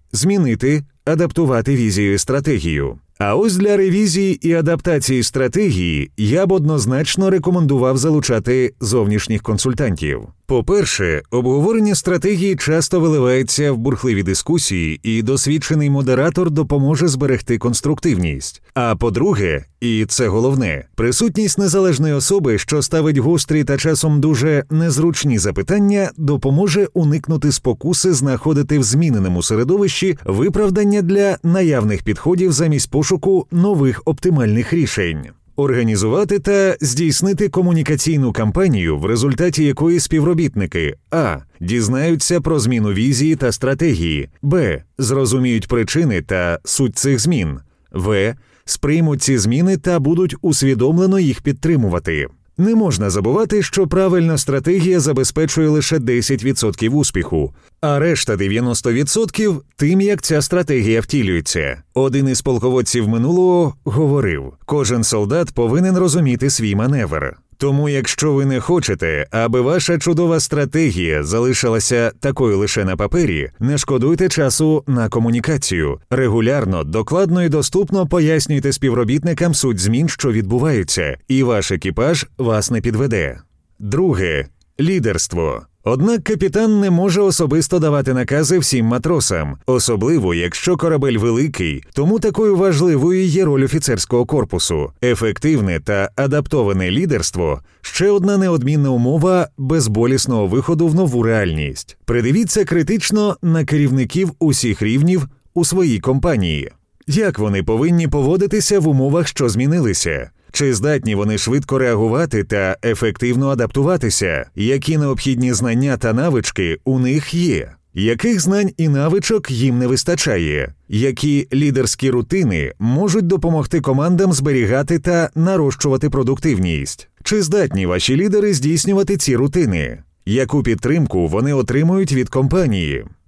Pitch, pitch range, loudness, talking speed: 140 Hz, 115-170 Hz, -16 LUFS, 115 wpm